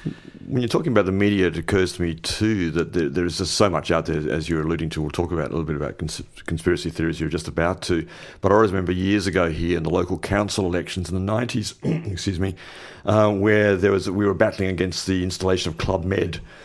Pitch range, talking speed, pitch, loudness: 85-100 Hz, 245 wpm, 90 Hz, -22 LUFS